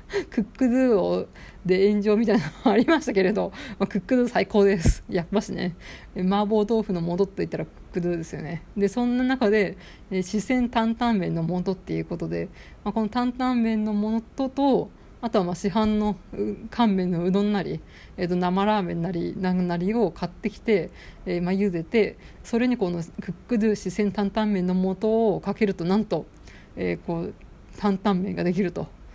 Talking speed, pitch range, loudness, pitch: 365 characters per minute, 180-220 Hz, -25 LUFS, 205 Hz